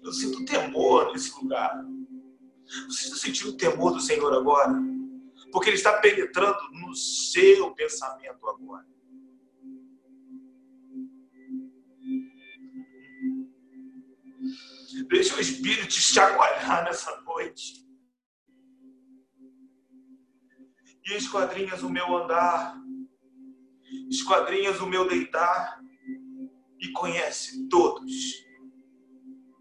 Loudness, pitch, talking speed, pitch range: -25 LUFS, 260 Hz, 80 wpm, 235-265 Hz